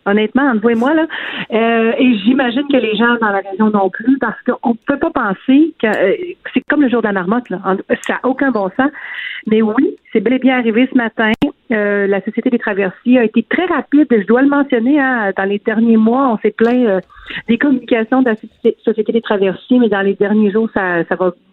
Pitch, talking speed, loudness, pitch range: 235 Hz, 235 wpm, -14 LUFS, 215-265 Hz